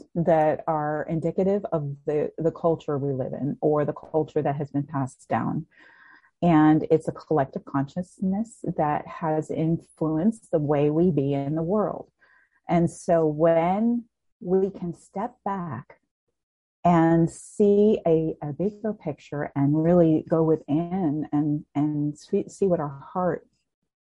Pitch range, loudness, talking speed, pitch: 150-180 Hz, -25 LUFS, 140 wpm, 165 Hz